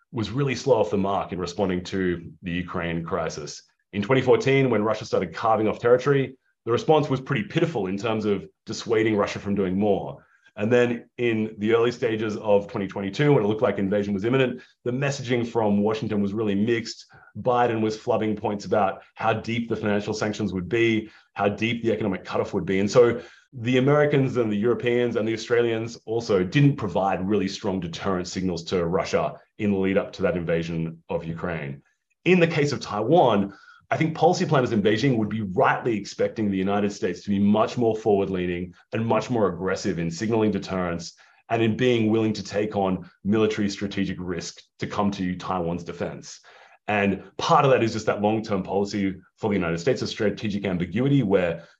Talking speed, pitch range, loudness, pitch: 190 wpm, 100-120 Hz, -24 LUFS, 105 Hz